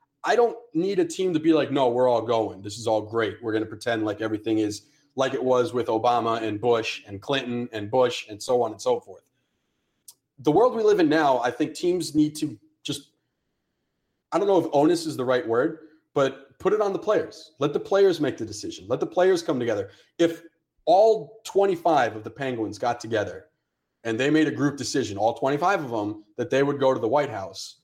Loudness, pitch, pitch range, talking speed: -24 LUFS, 140 Hz, 115-170 Hz, 225 wpm